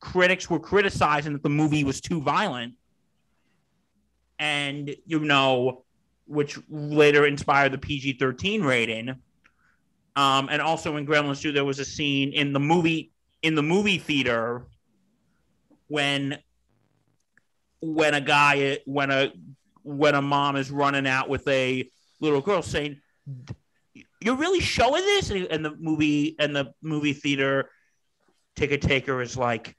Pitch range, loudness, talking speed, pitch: 135-155 Hz, -24 LUFS, 140 wpm, 145 Hz